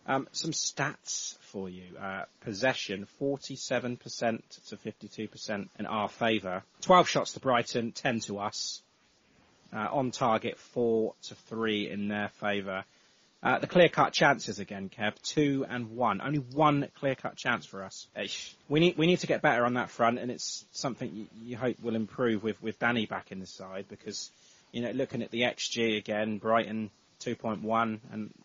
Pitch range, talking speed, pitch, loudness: 105-125 Hz, 175 wpm, 115 Hz, -30 LUFS